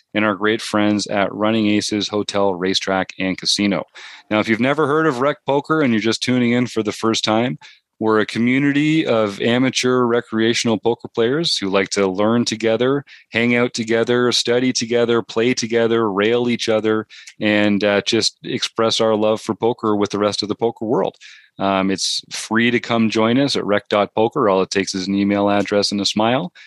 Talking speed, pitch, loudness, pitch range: 190 wpm, 110 Hz, -18 LUFS, 105-120 Hz